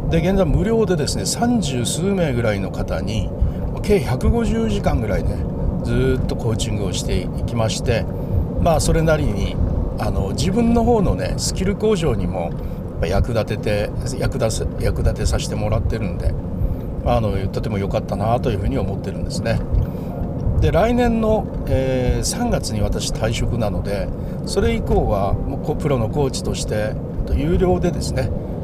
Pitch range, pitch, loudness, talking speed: 95-140 Hz, 115 Hz, -20 LUFS, 265 characters per minute